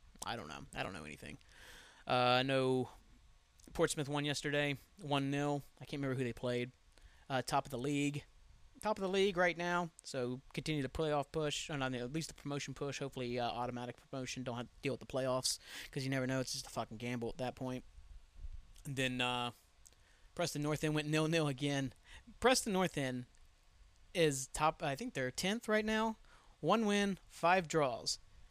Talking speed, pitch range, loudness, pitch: 190 wpm, 125-155 Hz, -37 LUFS, 135 Hz